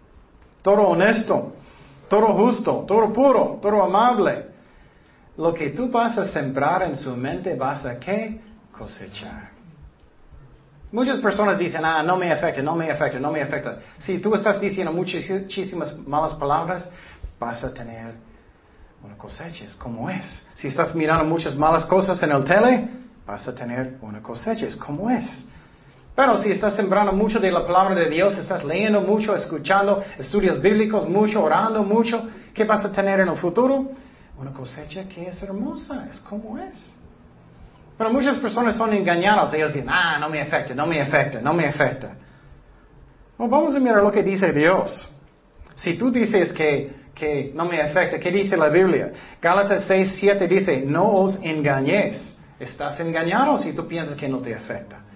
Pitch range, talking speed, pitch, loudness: 150-210 Hz, 165 wpm, 185 Hz, -21 LUFS